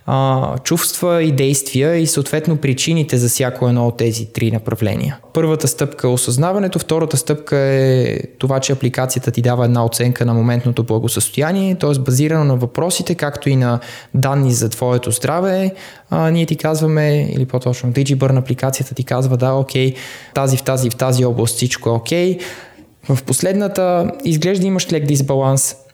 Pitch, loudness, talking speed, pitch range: 135 Hz, -16 LUFS, 160 wpm, 125-155 Hz